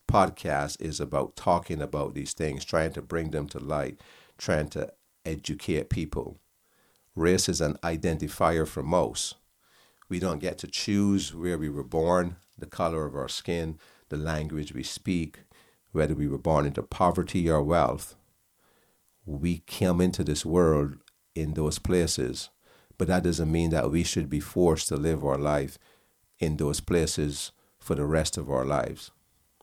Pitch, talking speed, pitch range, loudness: 80 Hz, 160 wpm, 75-90 Hz, -28 LUFS